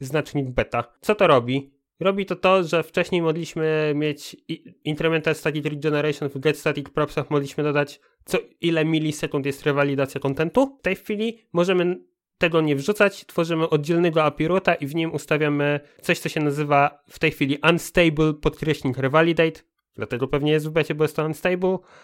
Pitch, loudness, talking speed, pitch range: 155 Hz, -22 LUFS, 165 wpm, 145-170 Hz